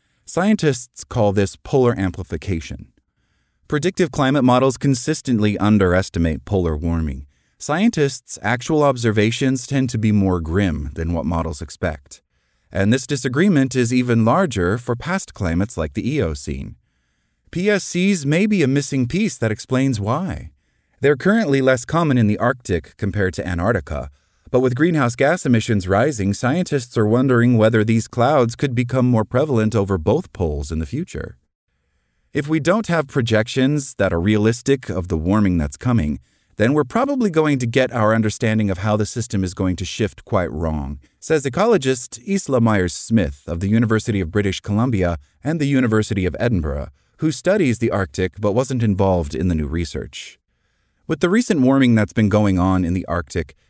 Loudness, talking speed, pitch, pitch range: -19 LUFS, 165 wpm, 110 Hz, 90-135 Hz